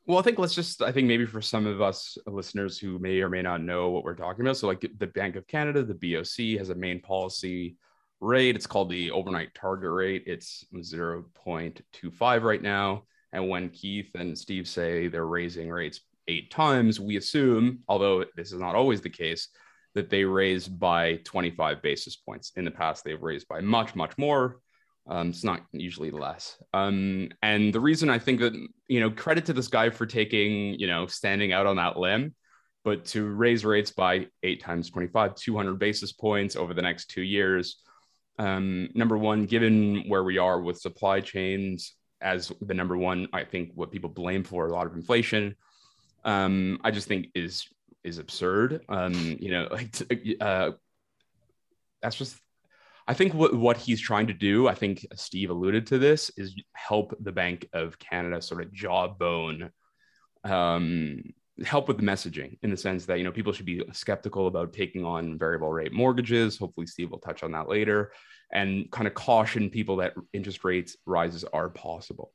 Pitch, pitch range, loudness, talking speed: 95 Hz, 90-110 Hz, -28 LUFS, 185 wpm